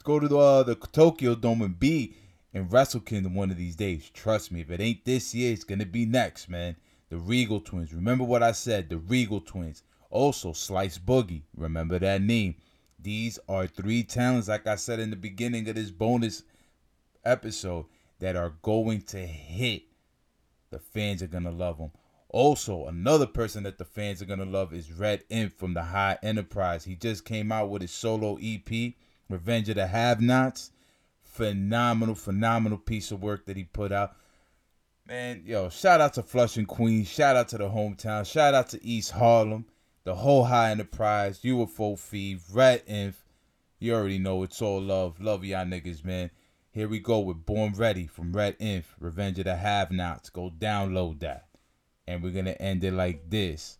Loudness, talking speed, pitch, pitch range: -28 LUFS, 190 wpm, 100 Hz, 90-115 Hz